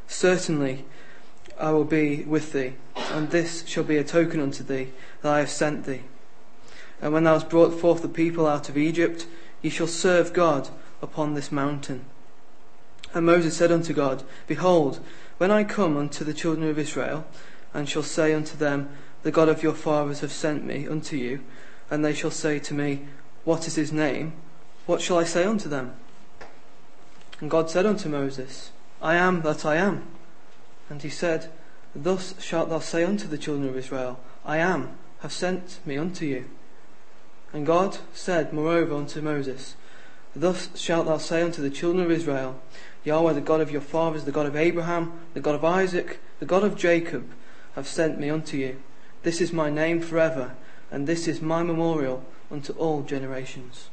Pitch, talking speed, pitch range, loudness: 155 Hz, 180 wpm, 145-165 Hz, -25 LUFS